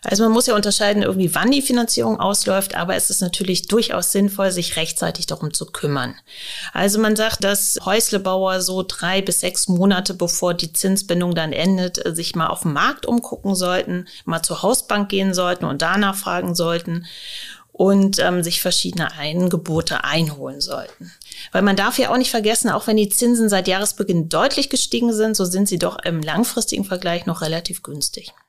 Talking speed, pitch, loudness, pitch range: 180 wpm, 190 Hz, -19 LUFS, 175-215 Hz